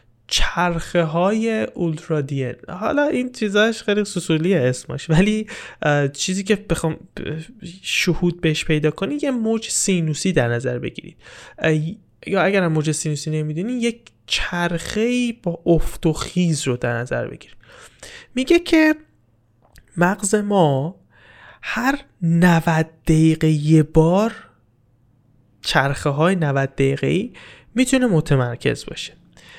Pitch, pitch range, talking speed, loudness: 170 Hz, 150-205 Hz, 115 wpm, -20 LUFS